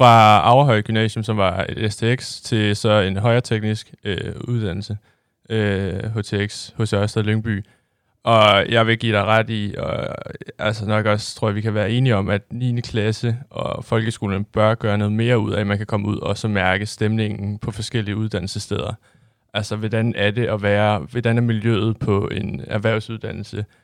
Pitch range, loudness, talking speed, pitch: 105-115 Hz, -20 LUFS, 180 wpm, 110 Hz